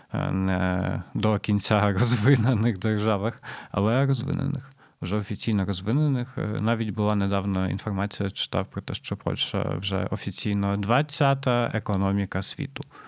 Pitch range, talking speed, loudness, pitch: 100-120 Hz, 110 wpm, -26 LUFS, 105 Hz